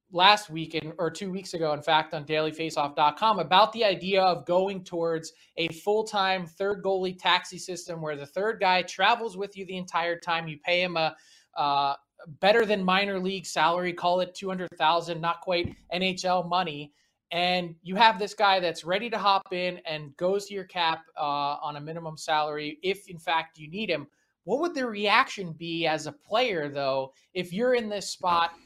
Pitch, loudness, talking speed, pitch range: 175 Hz, -27 LUFS, 185 wpm, 160-190 Hz